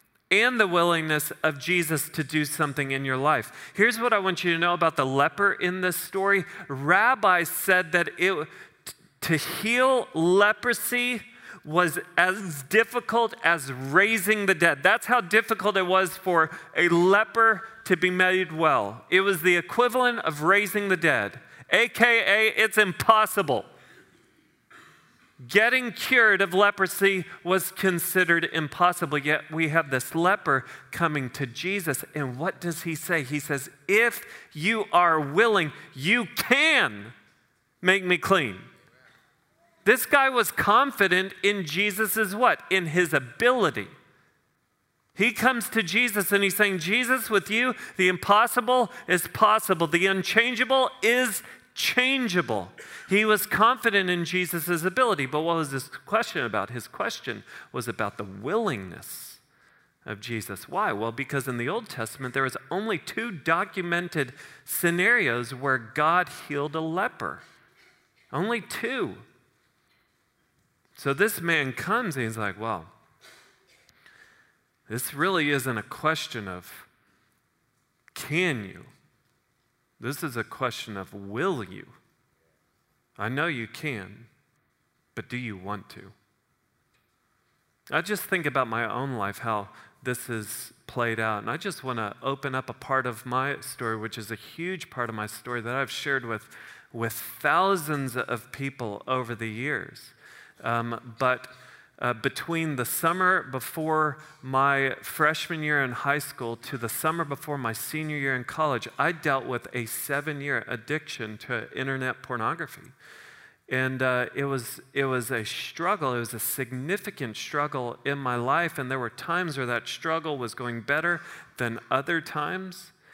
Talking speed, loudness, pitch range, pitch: 145 wpm, -25 LUFS, 130-190 Hz, 155 Hz